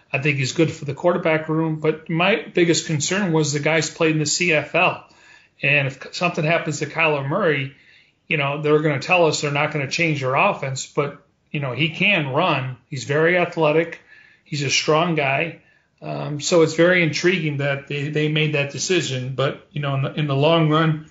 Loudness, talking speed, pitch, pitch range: -20 LUFS, 205 wpm, 155 Hz, 145-165 Hz